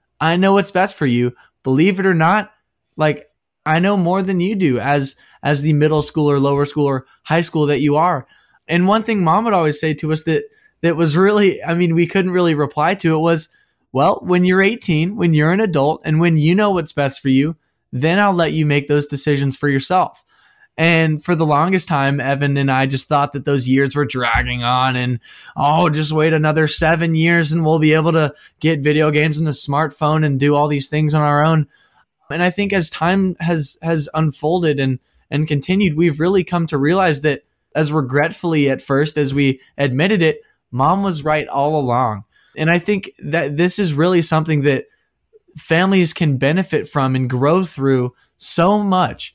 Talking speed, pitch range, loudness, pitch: 205 wpm, 145-175 Hz, -16 LUFS, 155 Hz